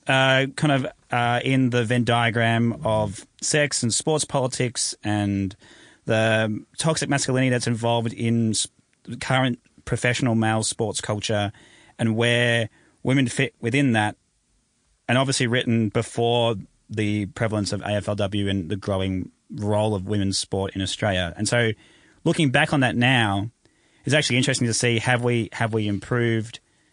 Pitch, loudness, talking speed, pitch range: 115 Hz, -23 LUFS, 150 wpm, 105-125 Hz